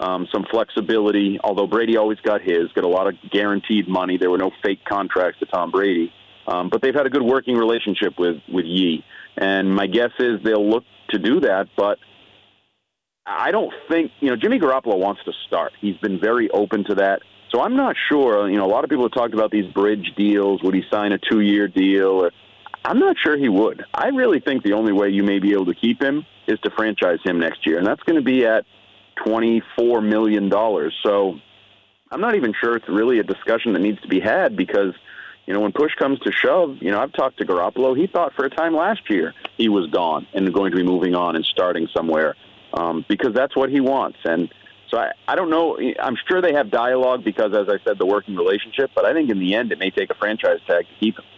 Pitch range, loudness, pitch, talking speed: 95-120 Hz, -20 LUFS, 105 Hz, 235 wpm